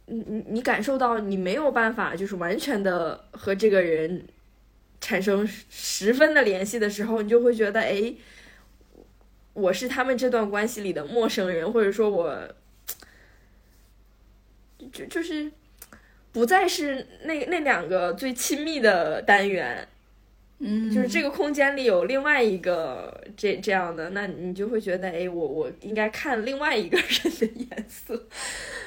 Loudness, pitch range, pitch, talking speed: -25 LUFS, 190-255 Hz, 220 Hz, 220 characters per minute